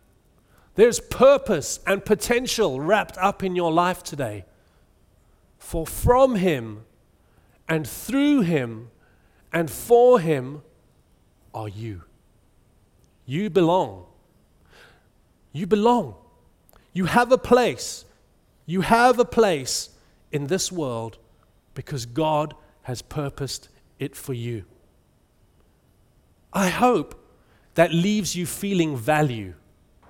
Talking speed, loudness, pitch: 100 wpm, -22 LUFS, 150 Hz